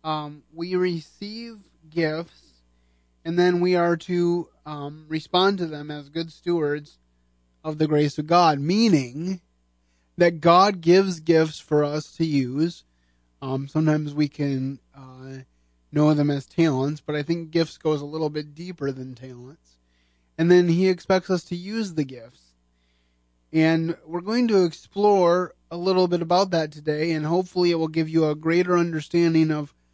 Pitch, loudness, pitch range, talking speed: 155 Hz, -23 LUFS, 135-175 Hz, 160 wpm